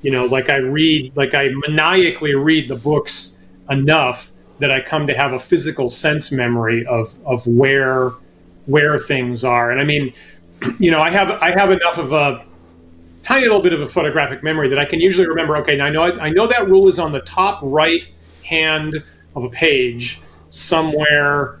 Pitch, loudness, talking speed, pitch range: 145 Hz, -15 LUFS, 190 wpm, 125-155 Hz